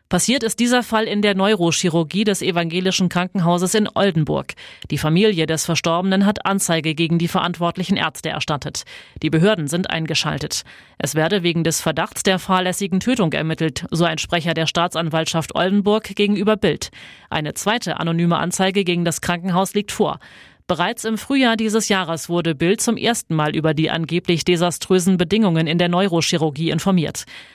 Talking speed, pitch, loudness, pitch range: 155 wpm, 175 Hz, -19 LUFS, 165-200 Hz